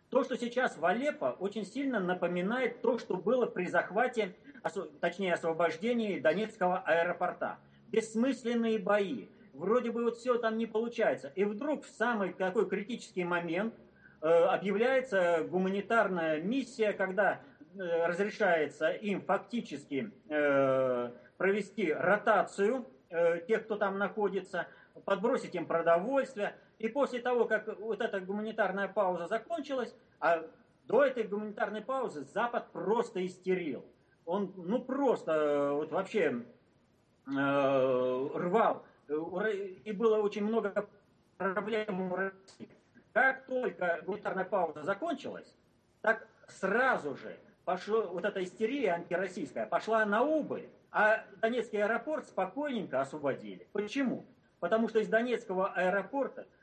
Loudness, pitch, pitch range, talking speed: -32 LUFS, 205 Hz, 175-230 Hz, 120 wpm